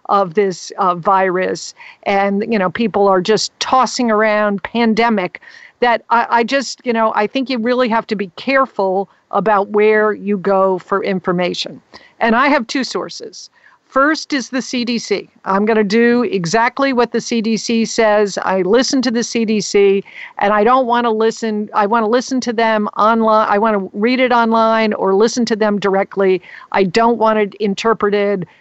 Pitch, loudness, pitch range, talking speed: 220 Hz, -15 LUFS, 200-235 Hz, 180 wpm